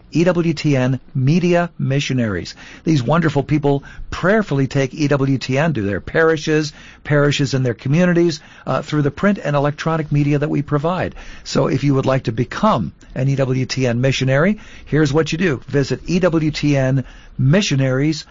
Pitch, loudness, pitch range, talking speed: 145 Hz, -18 LUFS, 135-160 Hz, 140 wpm